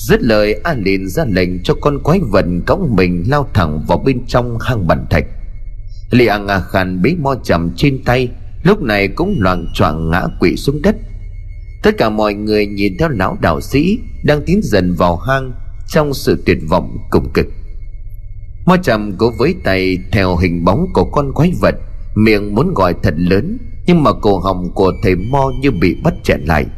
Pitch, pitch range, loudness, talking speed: 100 Hz, 95-130 Hz, -14 LUFS, 195 wpm